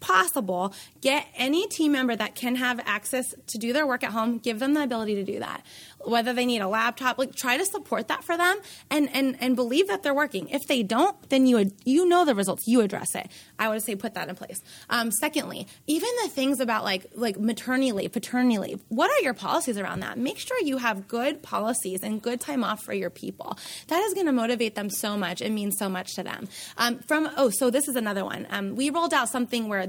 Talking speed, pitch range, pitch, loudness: 235 wpm, 215-280 Hz, 245 Hz, -26 LUFS